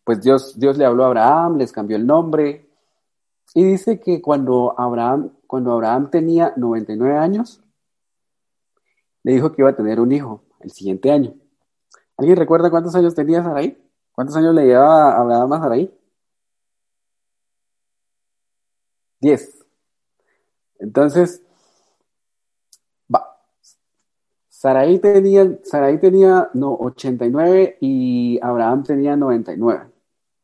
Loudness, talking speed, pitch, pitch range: -16 LUFS, 125 wpm, 135 Hz, 115-165 Hz